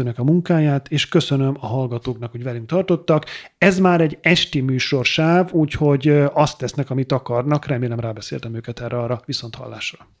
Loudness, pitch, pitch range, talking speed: -19 LUFS, 140 Hz, 120-155 Hz, 160 wpm